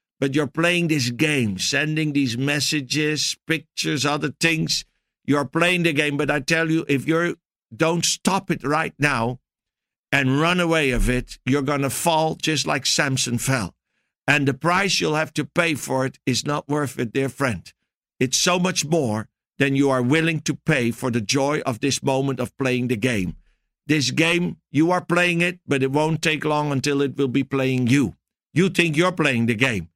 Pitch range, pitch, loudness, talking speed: 135-160 Hz, 145 Hz, -21 LUFS, 195 wpm